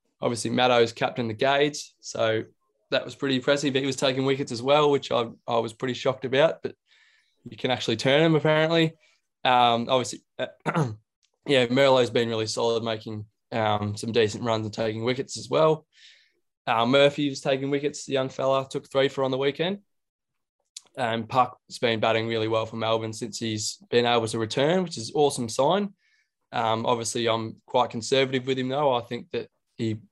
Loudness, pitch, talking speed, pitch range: -25 LUFS, 125 Hz, 185 wpm, 115-140 Hz